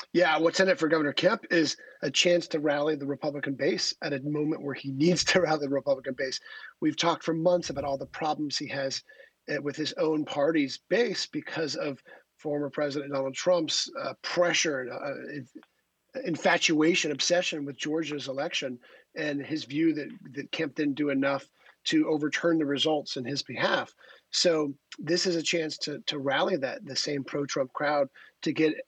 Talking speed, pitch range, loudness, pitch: 180 wpm, 140-165 Hz, -28 LUFS, 150 Hz